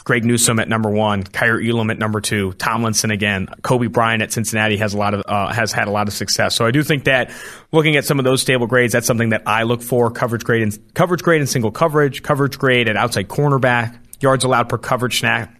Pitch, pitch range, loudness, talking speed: 120 Hz, 110-130 Hz, -17 LUFS, 240 wpm